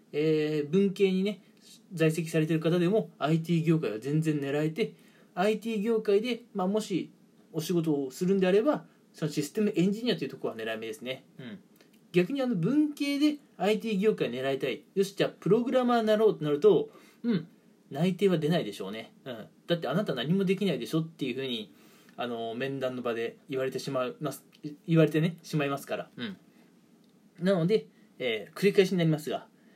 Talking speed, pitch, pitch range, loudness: 345 characters per minute, 190 Hz, 155-220 Hz, -29 LUFS